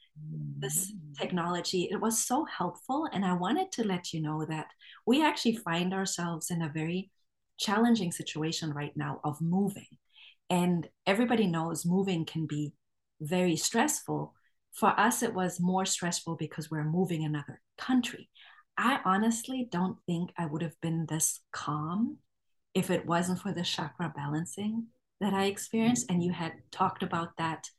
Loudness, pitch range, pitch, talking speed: -31 LUFS, 160-200 Hz, 175 Hz, 155 wpm